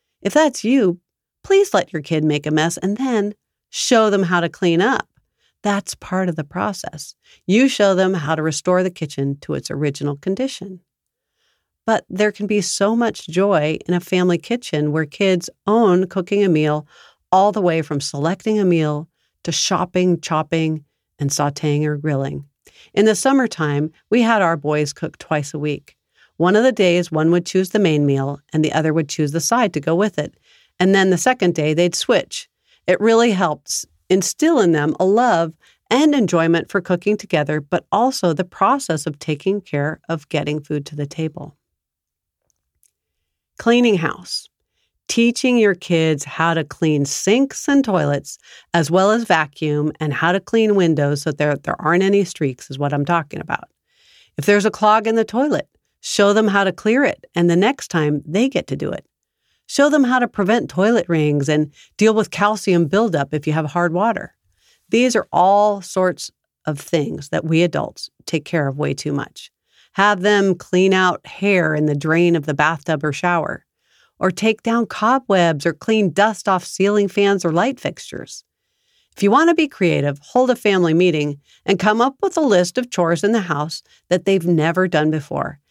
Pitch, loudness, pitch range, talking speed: 175 Hz, -18 LUFS, 155-205 Hz, 190 wpm